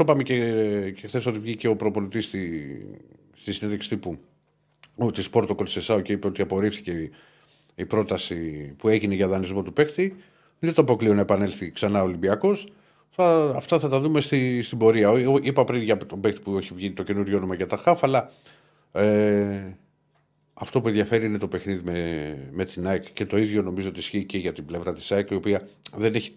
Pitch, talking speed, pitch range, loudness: 105 Hz, 190 wpm, 95-115 Hz, -24 LUFS